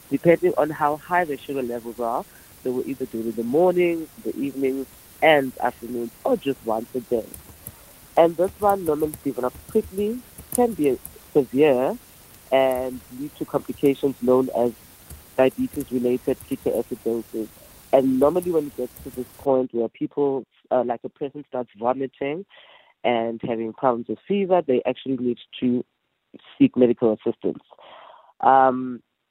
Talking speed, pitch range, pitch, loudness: 145 wpm, 120-150 Hz, 130 Hz, -23 LUFS